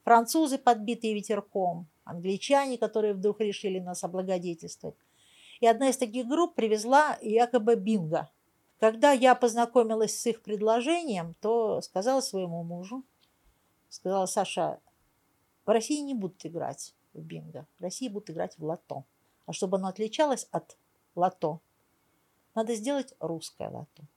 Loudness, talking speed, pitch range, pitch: -28 LUFS, 130 wpm, 180-245 Hz, 215 Hz